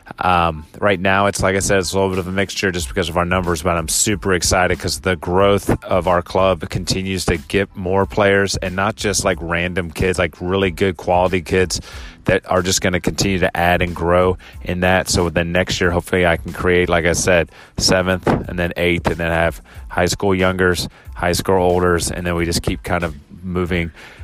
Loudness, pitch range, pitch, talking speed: -18 LUFS, 85-95 Hz, 90 Hz, 230 wpm